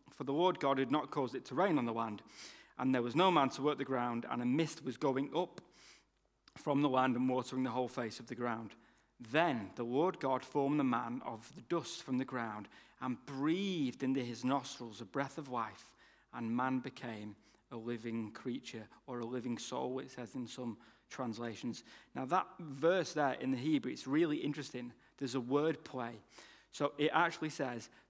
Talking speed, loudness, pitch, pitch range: 200 wpm, -37 LUFS, 130 Hz, 120-145 Hz